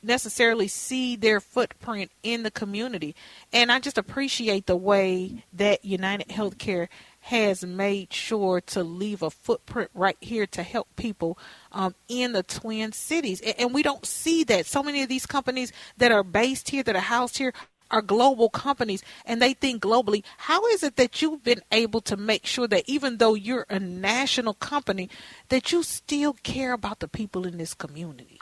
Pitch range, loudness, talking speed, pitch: 195-255 Hz, -25 LUFS, 180 wpm, 225 Hz